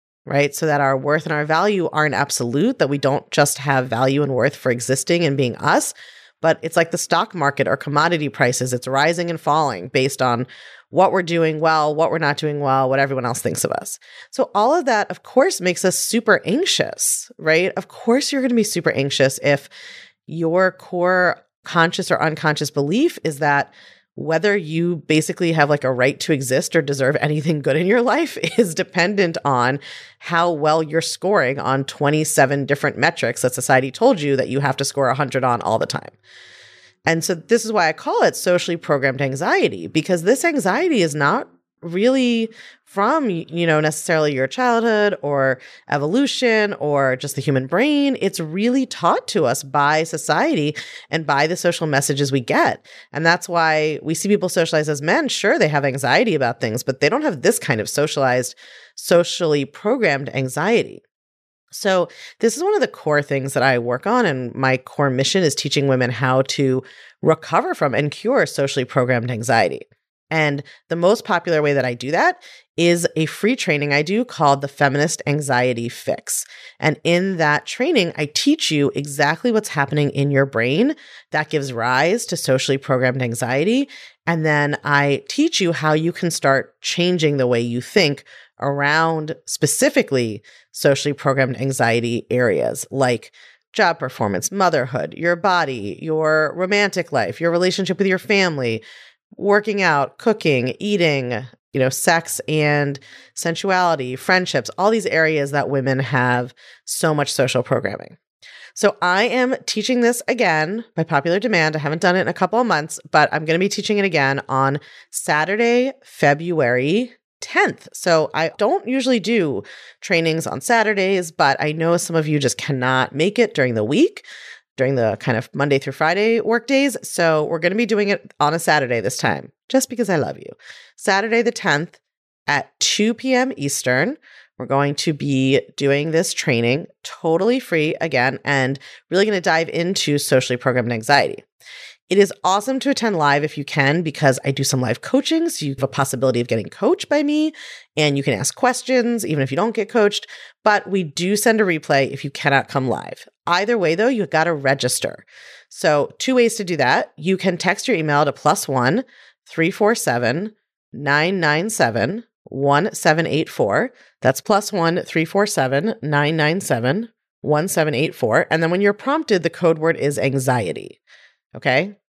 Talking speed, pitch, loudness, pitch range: 175 wpm, 160 Hz, -19 LUFS, 140-195 Hz